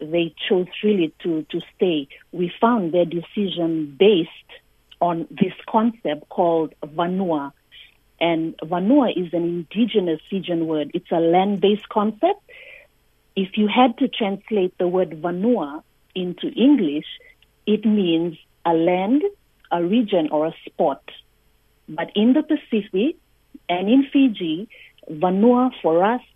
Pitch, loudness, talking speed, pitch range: 185 Hz, -21 LUFS, 130 wpm, 170-235 Hz